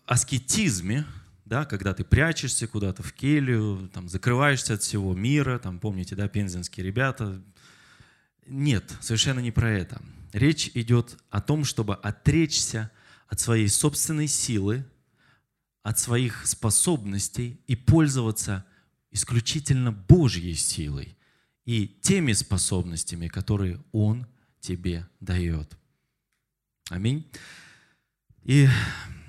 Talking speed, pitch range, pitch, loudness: 100 wpm, 100-135 Hz, 115 Hz, -25 LUFS